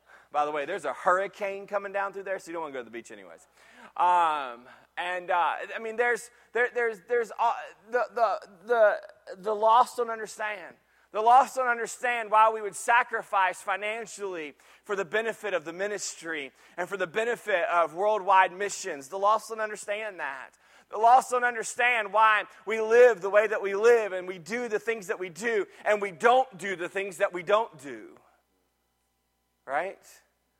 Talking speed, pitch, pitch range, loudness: 185 wpm, 210 Hz, 190-230 Hz, -27 LUFS